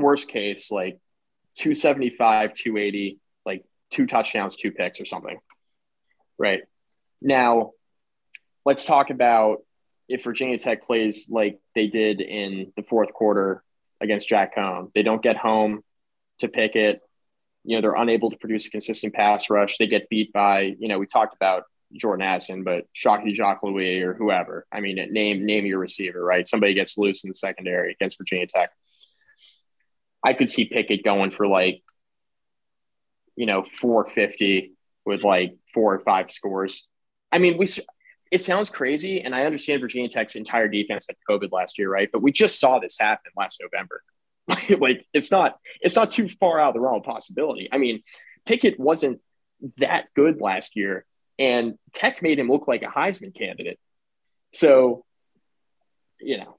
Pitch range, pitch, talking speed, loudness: 100-140 Hz, 110 Hz, 165 wpm, -22 LUFS